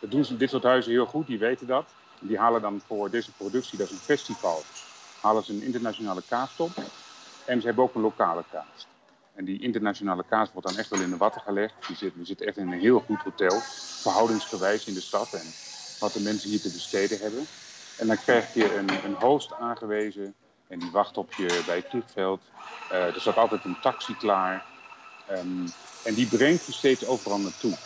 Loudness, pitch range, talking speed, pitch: -27 LUFS, 100-120 Hz, 210 wpm, 105 Hz